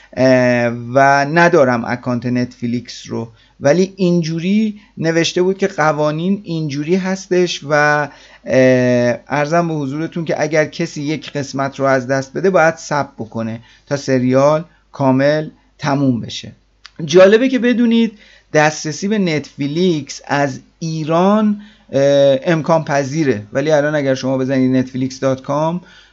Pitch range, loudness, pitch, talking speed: 130-170 Hz, -15 LUFS, 150 Hz, 115 wpm